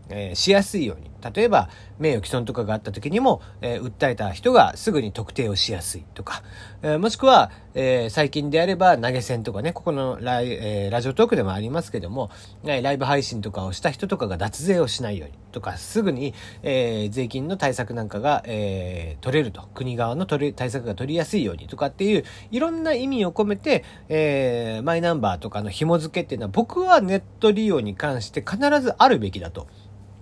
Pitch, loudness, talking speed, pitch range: 125 Hz, -23 LUFS, 395 characters per minute, 100-170 Hz